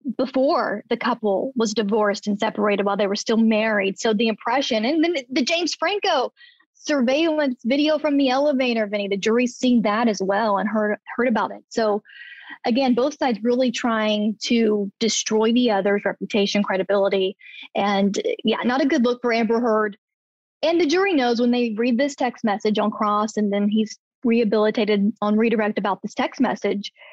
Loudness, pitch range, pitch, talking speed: -21 LUFS, 210-260 Hz, 230 Hz, 175 wpm